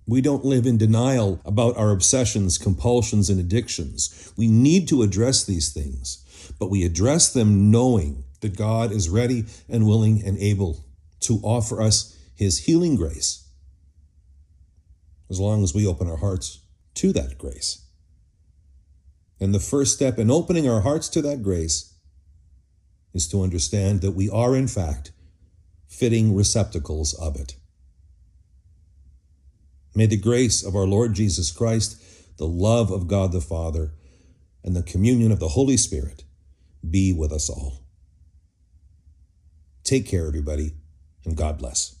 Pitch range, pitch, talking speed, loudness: 80-110 Hz, 90 Hz, 145 wpm, -22 LUFS